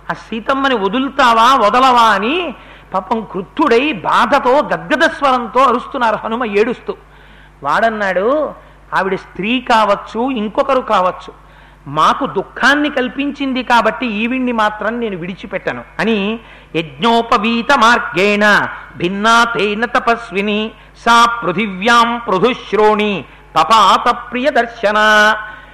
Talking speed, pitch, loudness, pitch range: 75 wpm, 225 Hz, -13 LUFS, 200-245 Hz